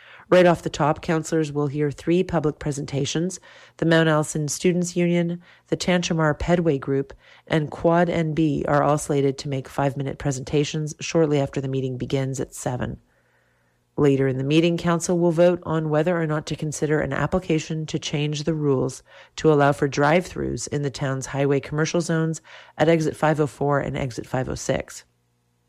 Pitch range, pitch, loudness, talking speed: 140-165 Hz, 150 Hz, -23 LUFS, 170 wpm